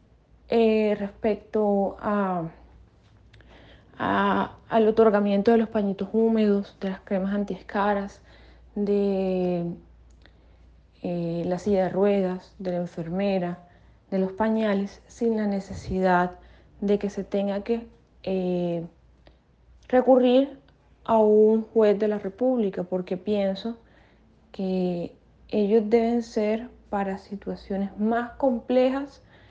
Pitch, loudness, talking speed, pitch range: 200 Hz, -25 LUFS, 105 wpm, 185-220 Hz